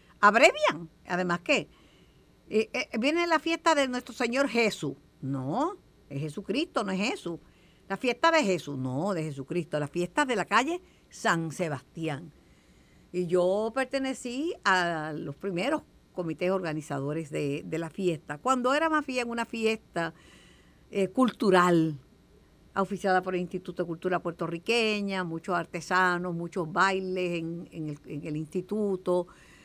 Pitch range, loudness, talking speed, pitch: 165-230 Hz, -29 LUFS, 140 wpm, 185 Hz